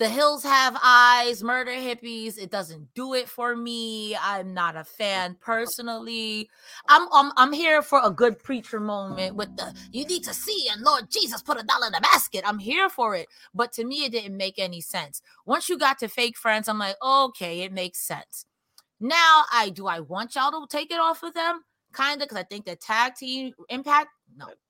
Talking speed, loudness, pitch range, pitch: 210 wpm, -23 LUFS, 205-280 Hz, 240 Hz